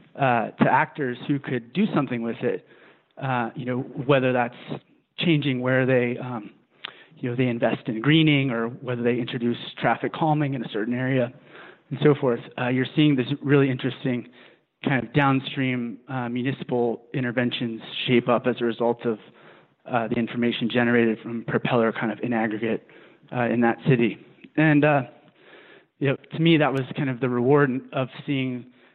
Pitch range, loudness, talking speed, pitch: 120-140 Hz, -24 LUFS, 170 wpm, 125 Hz